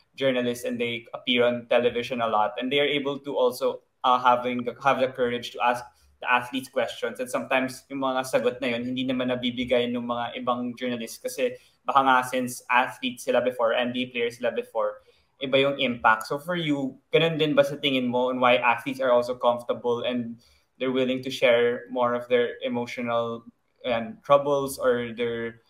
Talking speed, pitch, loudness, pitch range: 185 wpm, 125 Hz, -25 LUFS, 120-140 Hz